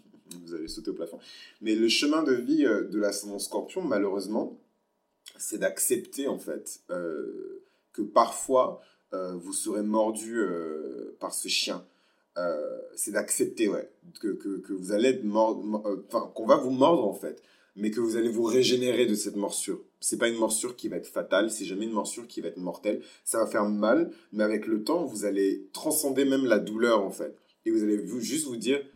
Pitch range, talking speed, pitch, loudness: 105-165 Hz, 200 wpm, 115 Hz, -28 LUFS